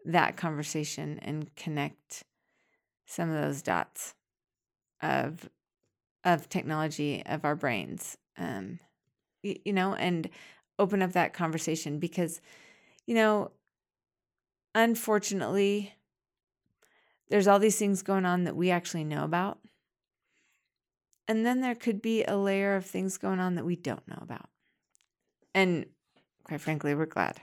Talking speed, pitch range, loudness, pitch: 125 wpm, 155-200 Hz, -30 LUFS, 180 Hz